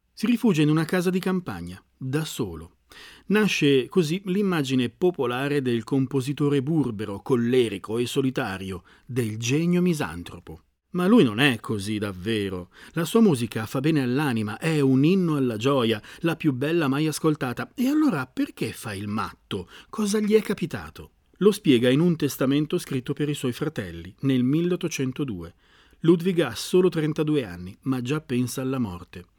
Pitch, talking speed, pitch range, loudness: 135 Hz, 155 wpm, 115-165 Hz, -24 LUFS